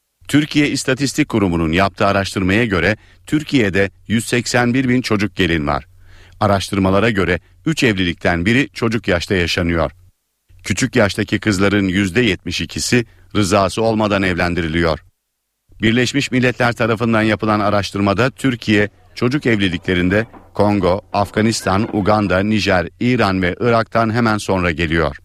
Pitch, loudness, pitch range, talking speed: 105 Hz, -16 LUFS, 95-115 Hz, 105 wpm